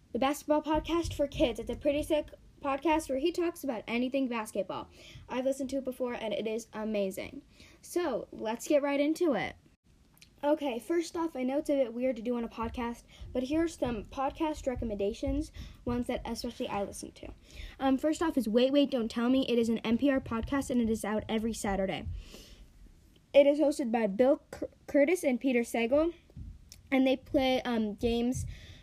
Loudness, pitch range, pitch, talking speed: -31 LUFS, 230-290 Hz, 260 Hz, 190 wpm